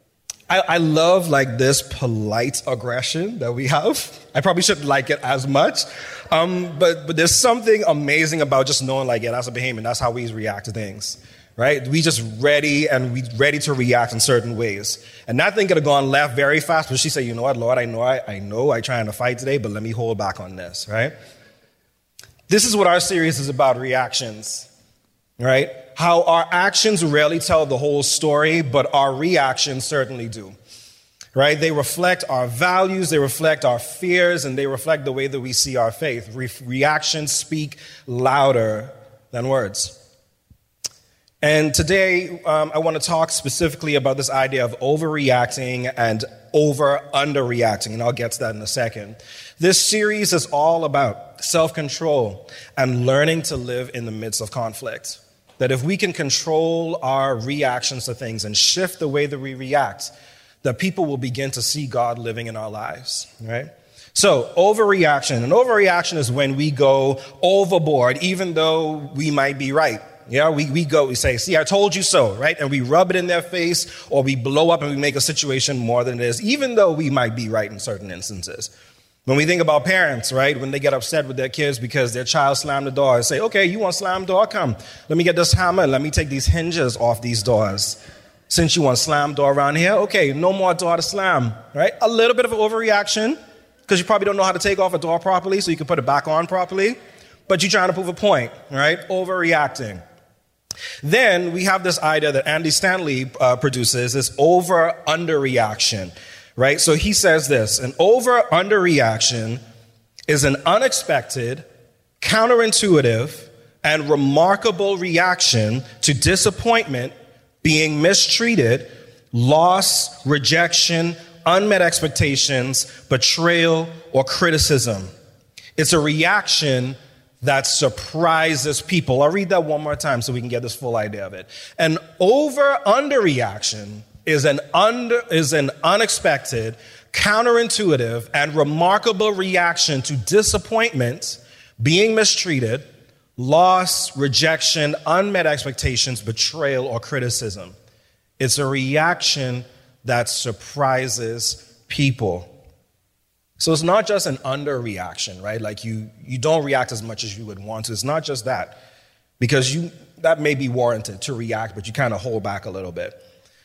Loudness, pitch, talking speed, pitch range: -18 LUFS, 140 Hz, 175 wpm, 120-165 Hz